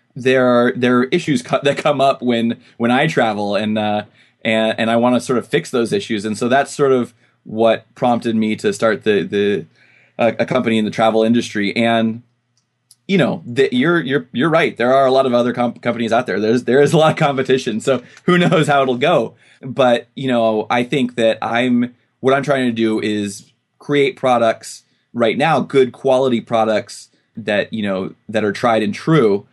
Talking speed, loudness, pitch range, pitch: 210 wpm, -16 LUFS, 115-135 Hz, 120 Hz